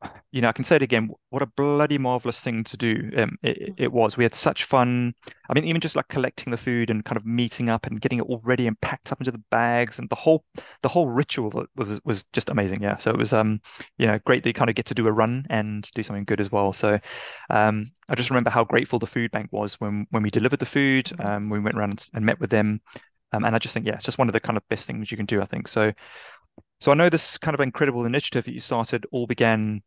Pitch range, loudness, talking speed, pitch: 110-130 Hz, -24 LUFS, 275 wpm, 115 Hz